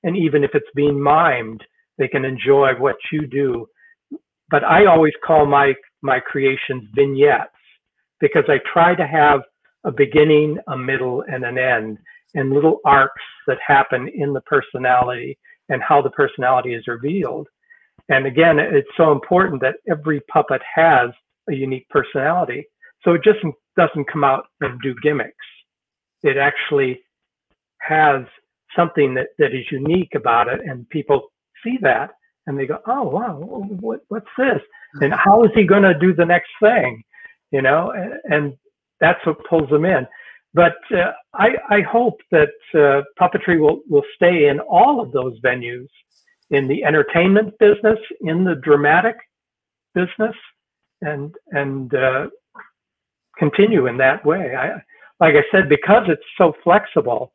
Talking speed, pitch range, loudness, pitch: 155 wpm, 140-205 Hz, -17 LUFS, 155 Hz